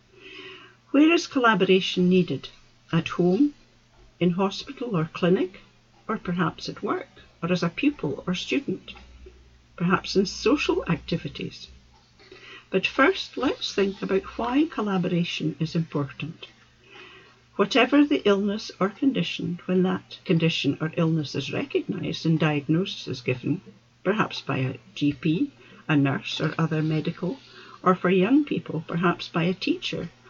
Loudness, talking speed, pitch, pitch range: -25 LUFS, 130 wpm, 175 Hz, 150-195 Hz